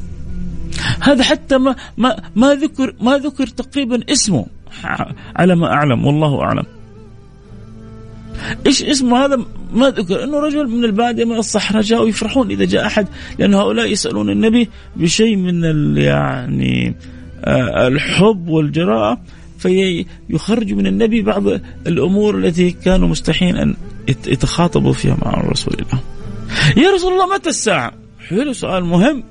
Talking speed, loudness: 130 wpm, -15 LUFS